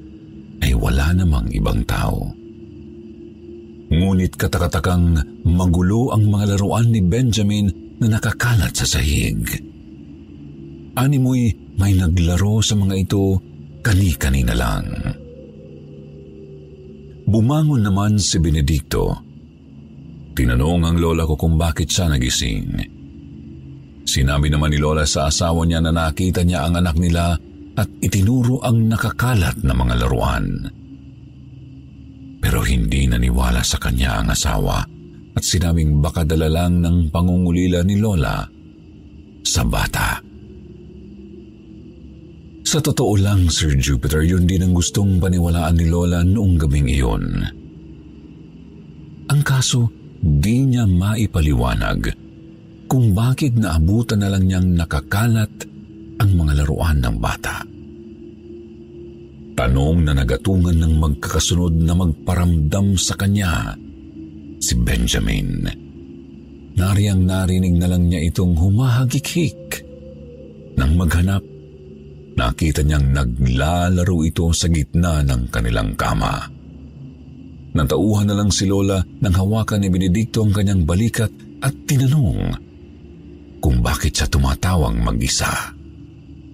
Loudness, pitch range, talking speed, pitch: -18 LUFS, 75-100 Hz, 105 wpm, 85 Hz